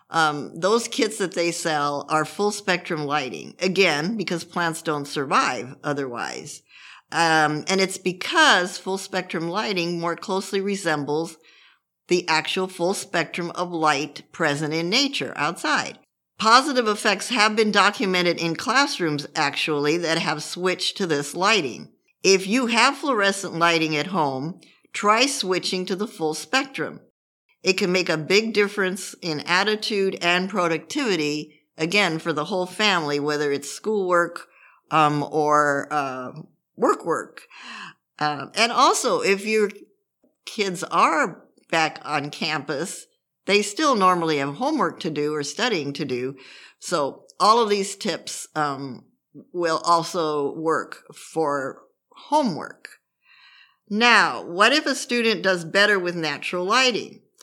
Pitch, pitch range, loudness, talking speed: 175 Hz, 155-205 Hz, -22 LUFS, 135 wpm